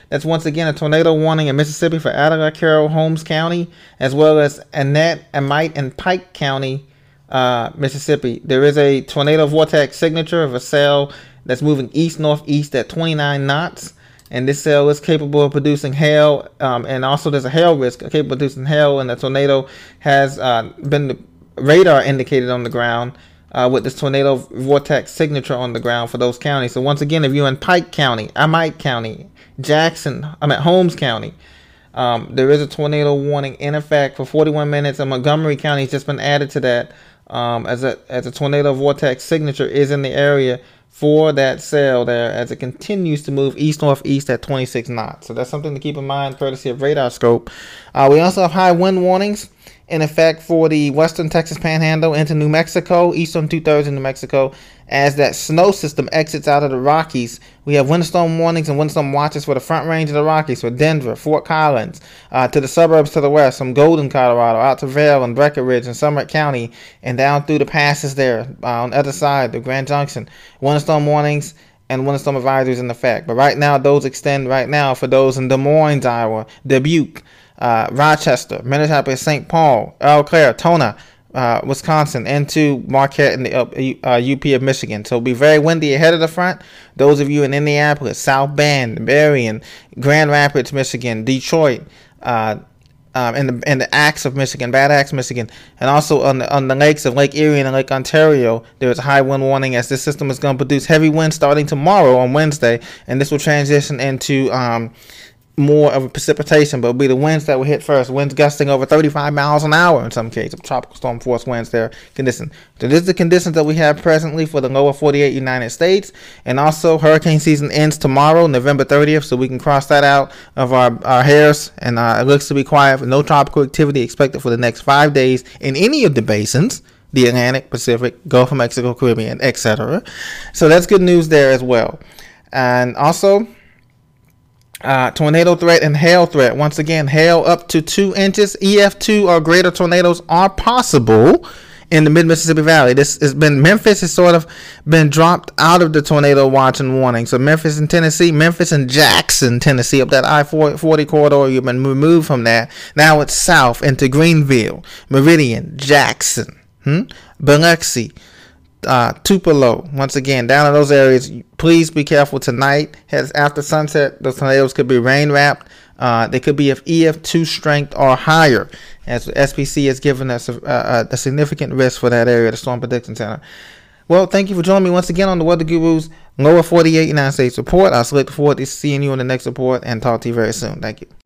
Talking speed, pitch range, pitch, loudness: 200 wpm, 130-155 Hz, 145 Hz, -14 LUFS